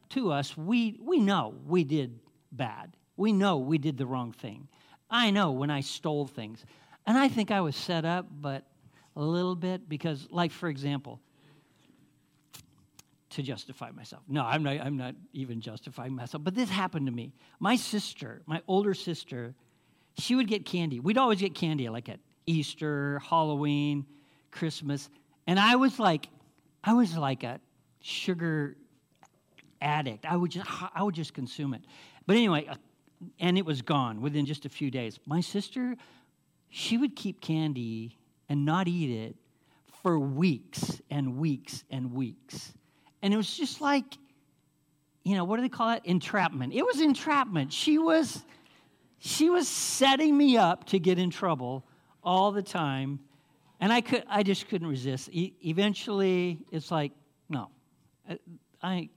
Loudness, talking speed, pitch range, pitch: -29 LUFS, 160 wpm, 140-195 Hz, 160 Hz